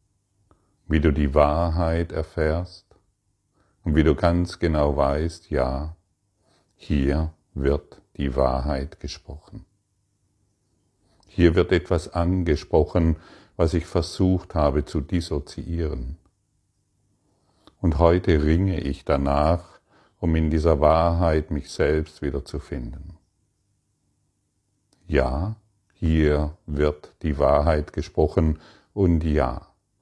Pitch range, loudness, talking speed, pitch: 75-95 Hz, -23 LUFS, 95 wpm, 85 Hz